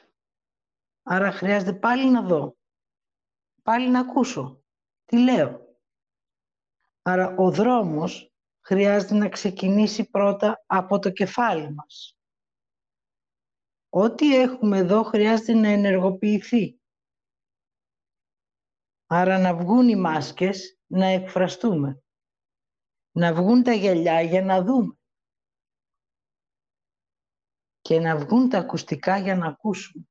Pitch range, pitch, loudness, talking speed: 180-225 Hz, 195 Hz, -22 LUFS, 100 wpm